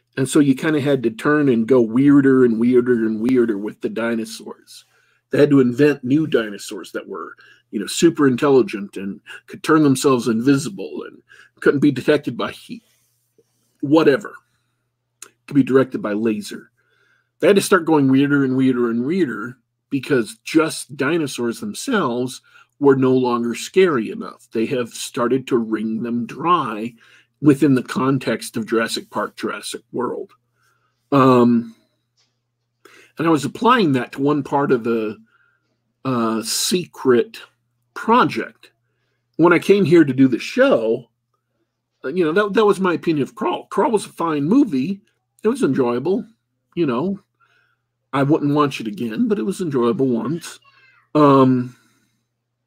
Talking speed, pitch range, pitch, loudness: 155 wpm, 120-155 Hz, 130 Hz, -18 LUFS